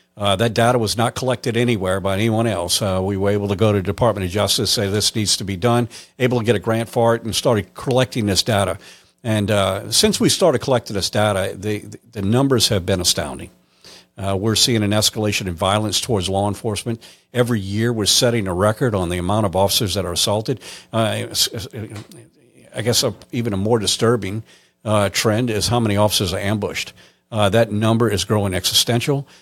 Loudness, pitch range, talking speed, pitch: -18 LUFS, 100-120 Hz, 200 wpm, 105 Hz